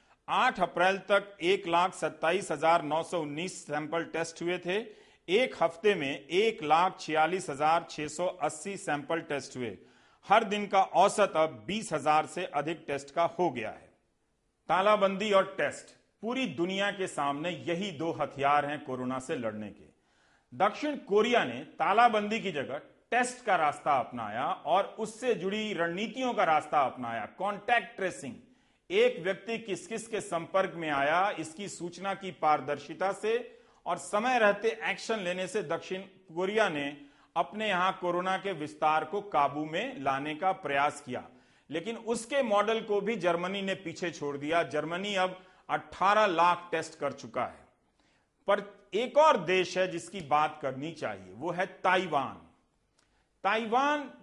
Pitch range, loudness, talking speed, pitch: 155-205 Hz, -30 LUFS, 155 wpm, 180 Hz